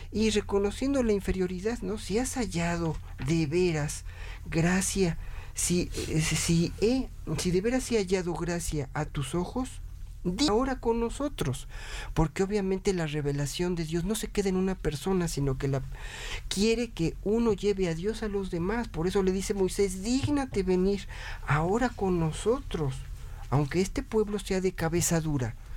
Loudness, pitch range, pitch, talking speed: -29 LUFS, 155-210 Hz, 185 Hz, 160 wpm